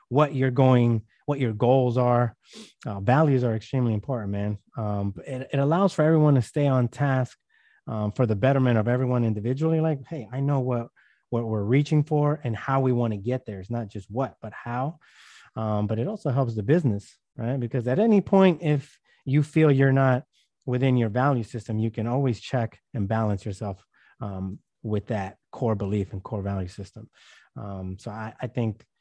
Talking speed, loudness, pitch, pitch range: 195 wpm, -25 LUFS, 125 Hz, 110-135 Hz